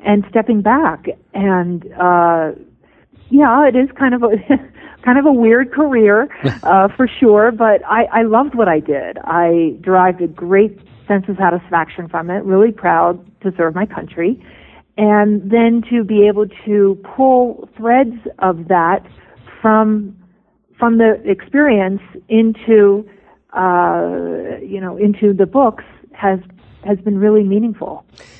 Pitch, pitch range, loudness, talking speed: 205 Hz, 185-230 Hz, -14 LUFS, 140 wpm